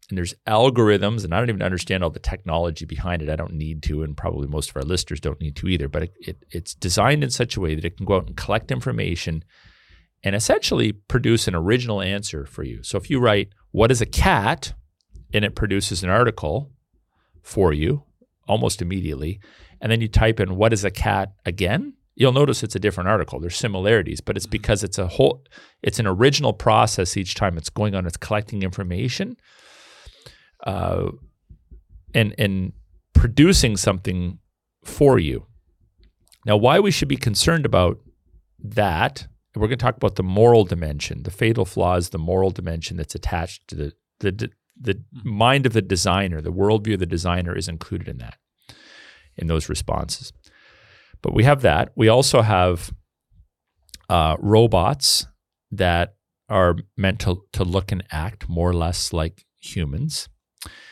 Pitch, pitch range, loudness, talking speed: 95 Hz, 85-110 Hz, -21 LUFS, 175 wpm